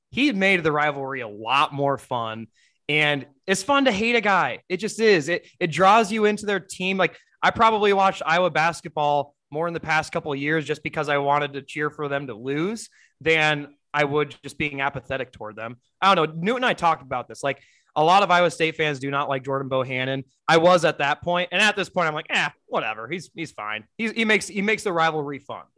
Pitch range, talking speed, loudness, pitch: 140-185 Hz, 235 wpm, -22 LUFS, 155 Hz